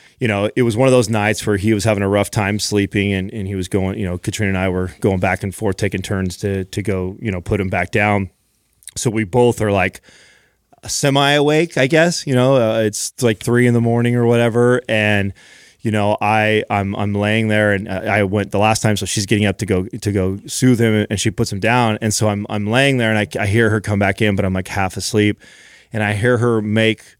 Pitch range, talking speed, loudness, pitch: 100-115 Hz, 255 wpm, -17 LUFS, 105 Hz